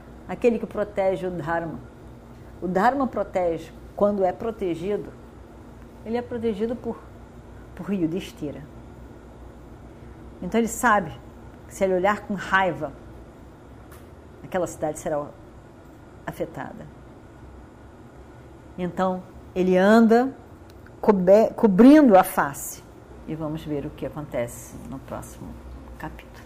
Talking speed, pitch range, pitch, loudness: 110 wpm, 140-205 Hz, 185 Hz, -23 LUFS